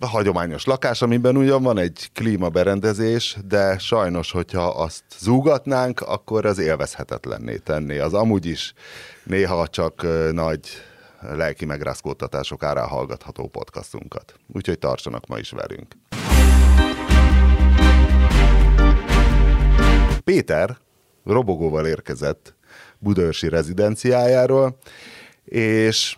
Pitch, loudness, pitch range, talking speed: 90 Hz, -19 LUFS, 75-110 Hz, 90 wpm